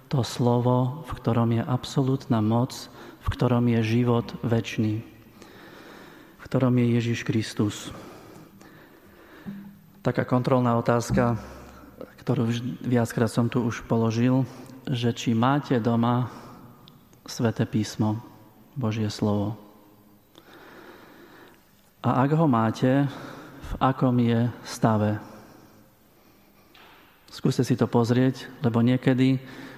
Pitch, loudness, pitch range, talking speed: 120 Hz, -25 LUFS, 115-130 Hz, 95 wpm